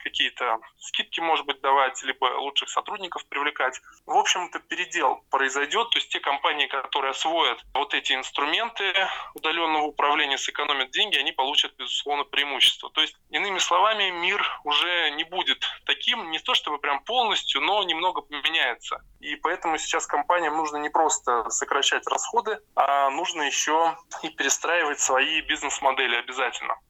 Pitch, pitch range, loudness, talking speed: 150 Hz, 140-160 Hz, -24 LUFS, 145 wpm